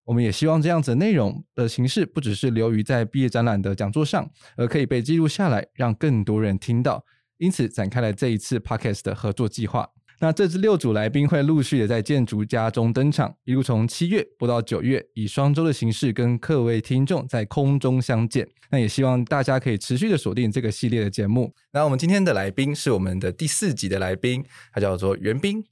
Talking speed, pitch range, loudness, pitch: 345 characters per minute, 110-145 Hz, -23 LUFS, 125 Hz